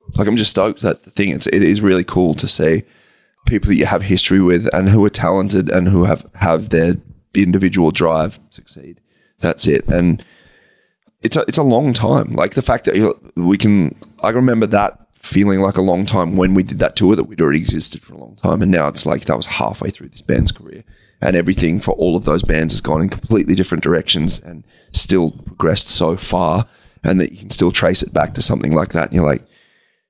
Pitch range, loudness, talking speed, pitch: 90-100 Hz, -15 LUFS, 230 wpm, 95 Hz